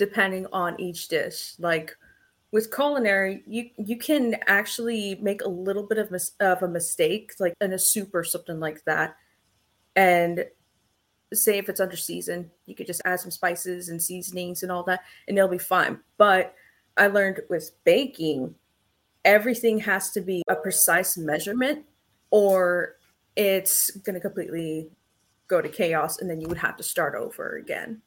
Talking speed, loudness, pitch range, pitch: 165 wpm, -24 LUFS, 175-215 Hz, 190 Hz